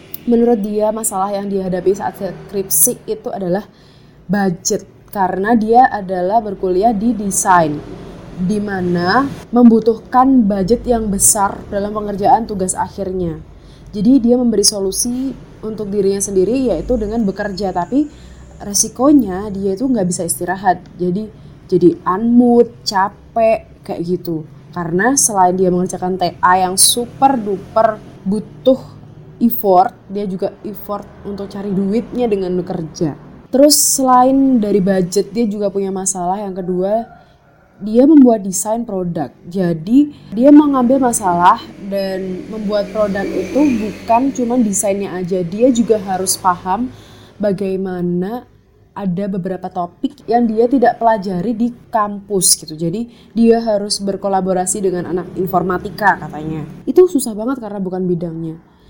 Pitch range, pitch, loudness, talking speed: 185-230 Hz, 200 Hz, -15 LUFS, 125 wpm